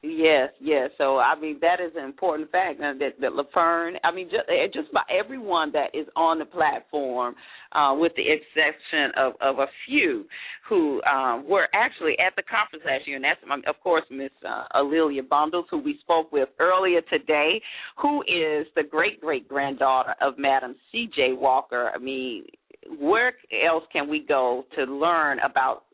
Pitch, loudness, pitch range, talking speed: 155 Hz, -24 LUFS, 140-180 Hz, 175 wpm